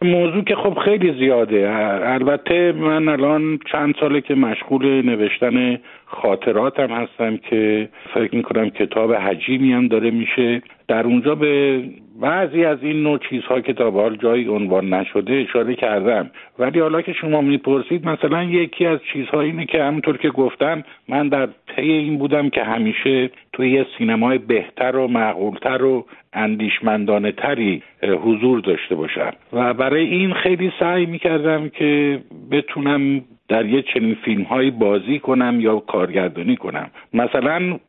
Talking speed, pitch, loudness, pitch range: 140 wpm, 135 Hz, -18 LUFS, 115-155 Hz